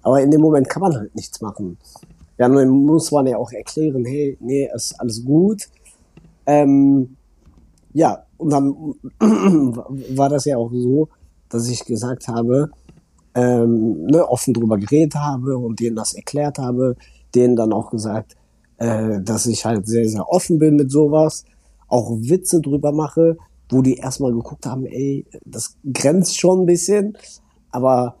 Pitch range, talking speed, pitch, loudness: 115-150 Hz, 160 wpm, 130 Hz, -18 LUFS